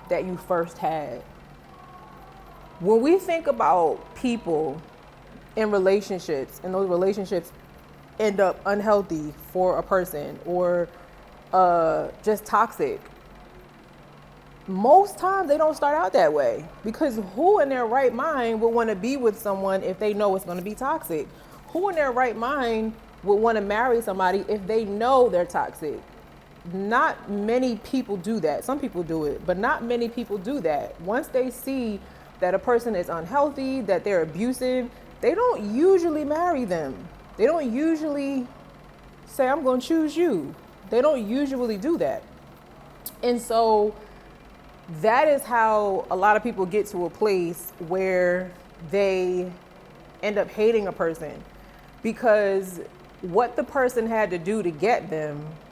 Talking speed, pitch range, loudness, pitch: 150 wpm, 185-255 Hz, -24 LUFS, 215 Hz